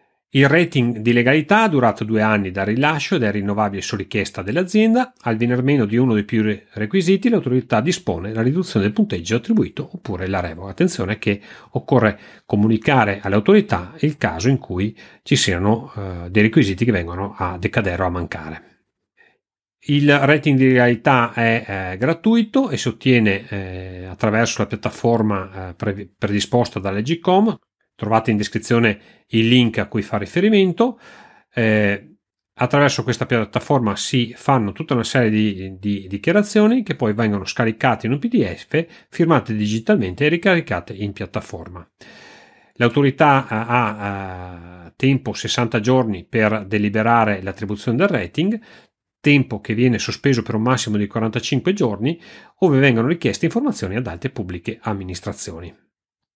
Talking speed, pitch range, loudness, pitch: 145 wpm, 105-140 Hz, -19 LUFS, 115 Hz